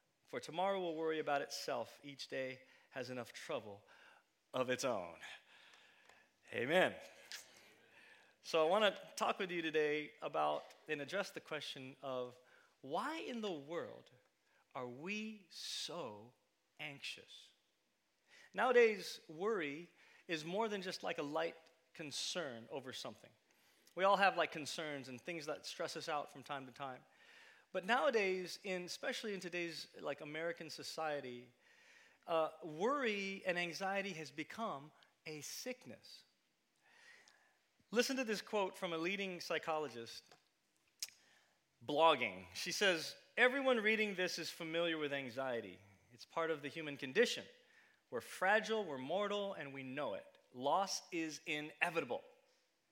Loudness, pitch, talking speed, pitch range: -40 LUFS, 165 Hz, 130 wpm, 140-195 Hz